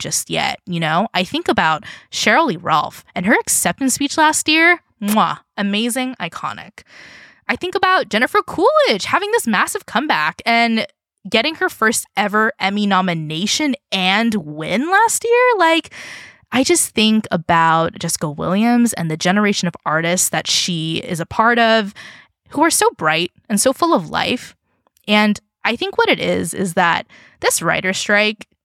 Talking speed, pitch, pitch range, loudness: 160 wpm, 220 Hz, 185-310 Hz, -16 LUFS